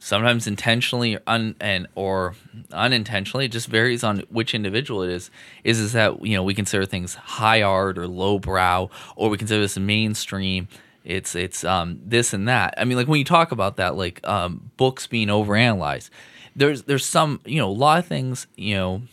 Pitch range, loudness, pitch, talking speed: 95-120 Hz, -21 LUFS, 105 Hz, 200 wpm